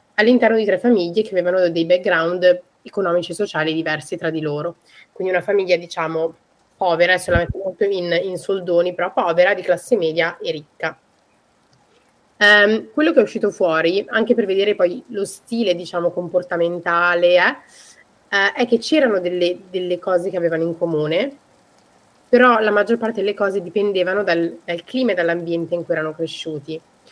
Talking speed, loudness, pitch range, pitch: 160 wpm, -18 LUFS, 170-205 Hz, 180 Hz